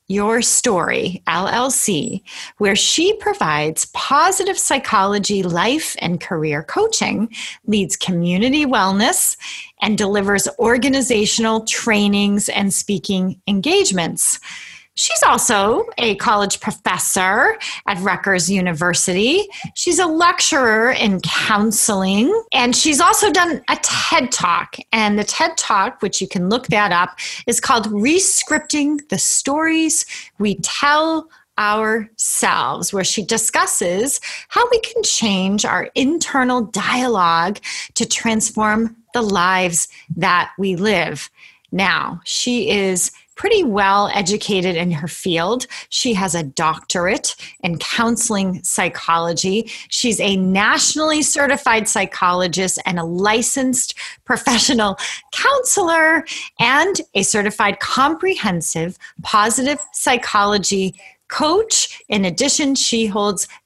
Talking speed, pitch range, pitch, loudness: 105 wpm, 195-280 Hz, 220 Hz, -16 LUFS